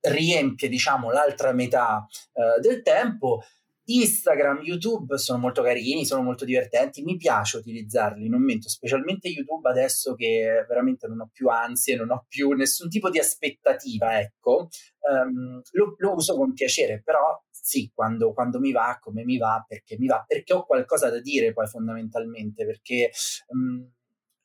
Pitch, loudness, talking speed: 135 Hz, -24 LUFS, 155 wpm